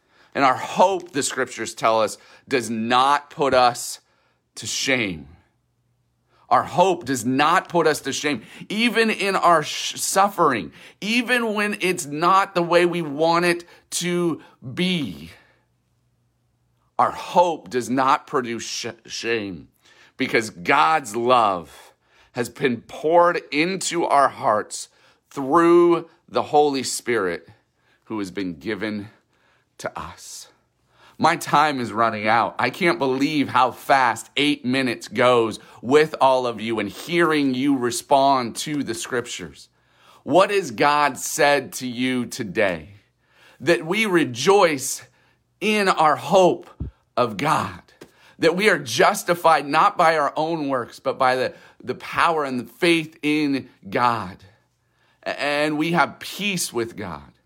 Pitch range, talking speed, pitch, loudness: 120-170 Hz, 130 wpm, 140 Hz, -21 LUFS